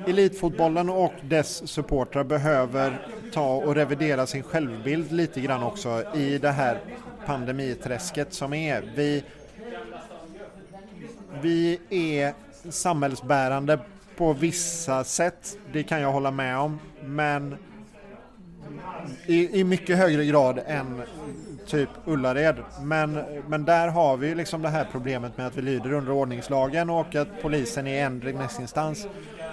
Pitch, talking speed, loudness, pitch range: 150 Hz, 125 wpm, -26 LUFS, 140-170 Hz